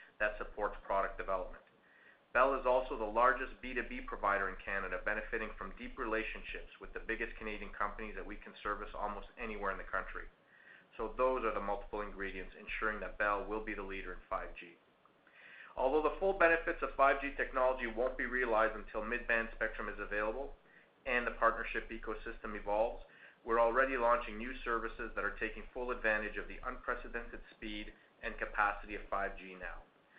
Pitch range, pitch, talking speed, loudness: 105-125 Hz, 115 Hz, 170 wpm, -37 LUFS